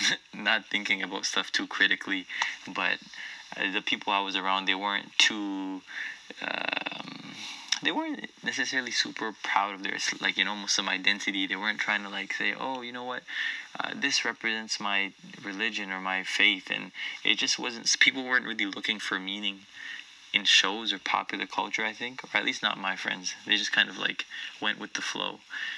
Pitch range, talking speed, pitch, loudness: 95-115 Hz, 180 wpm, 100 Hz, -28 LUFS